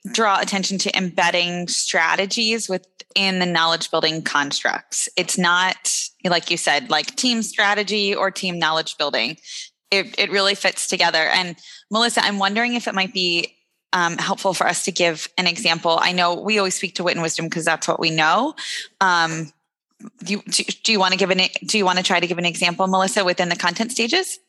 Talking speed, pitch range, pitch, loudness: 200 wpm, 175-205 Hz, 185 Hz, -19 LUFS